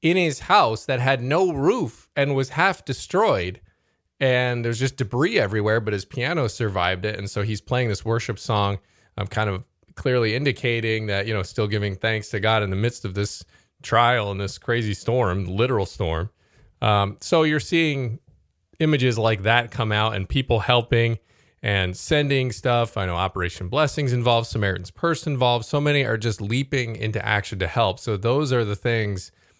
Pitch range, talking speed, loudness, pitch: 100-130 Hz, 180 wpm, -22 LUFS, 115 Hz